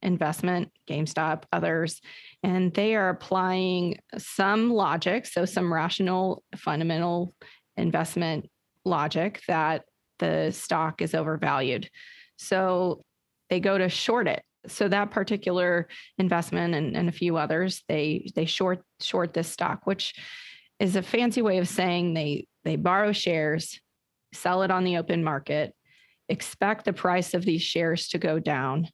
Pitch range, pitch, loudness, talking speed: 165-190 Hz, 180 Hz, -27 LUFS, 140 wpm